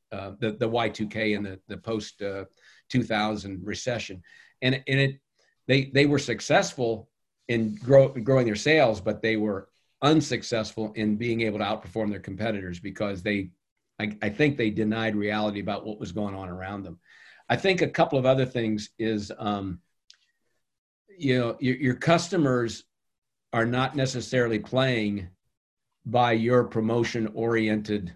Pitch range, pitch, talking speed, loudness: 105-125 Hz, 110 Hz, 160 wpm, -26 LUFS